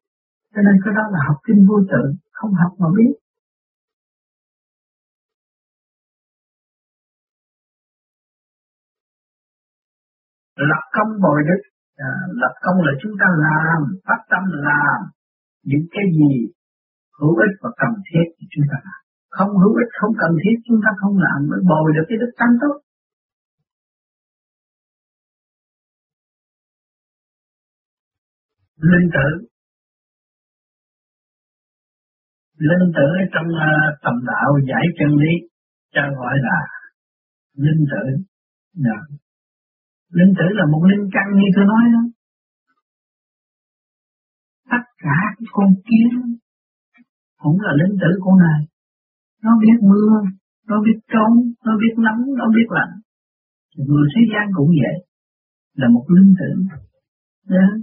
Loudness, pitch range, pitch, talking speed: -16 LUFS, 150-215 Hz, 185 Hz, 120 wpm